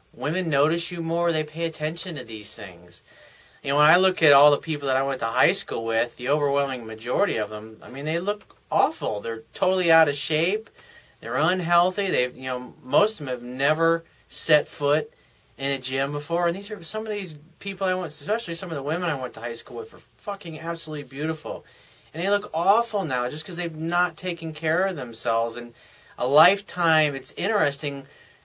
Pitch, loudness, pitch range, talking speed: 155 Hz, -24 LUFS, 135-175 Hz, 210 wpm